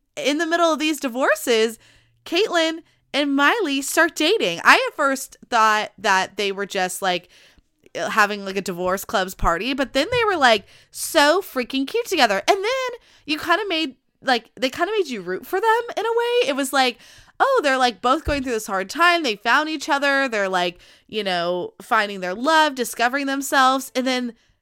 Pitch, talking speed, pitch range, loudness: 270 Hz, 195 wpm, 215-320 Hz, -20 LUFS